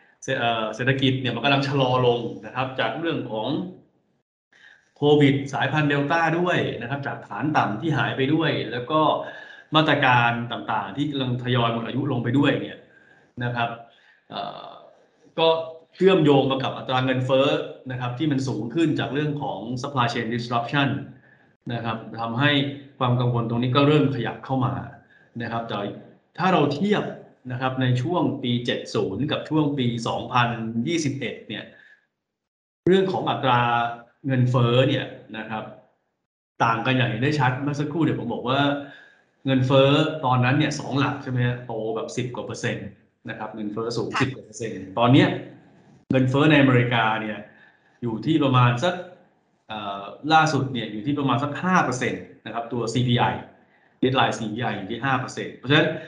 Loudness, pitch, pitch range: -23 LUFS, 130 Hz, 120-145 Hz